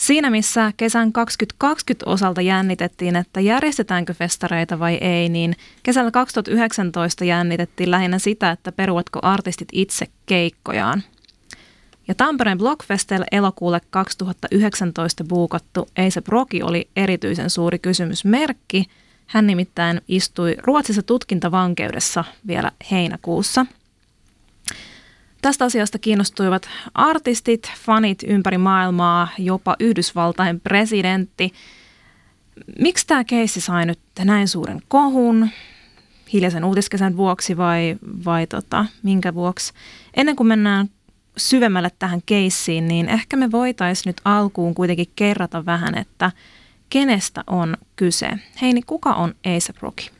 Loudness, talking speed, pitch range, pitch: -19 LUFS, 110 wpm, 175-220 Hz, 190 Hz